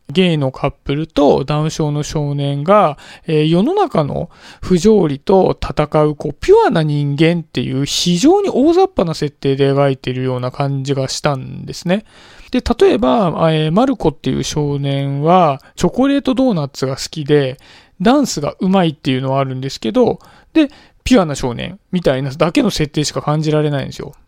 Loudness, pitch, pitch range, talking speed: -15 LUFS, 155 Hz, 140-190 Hz, 360 characters per minute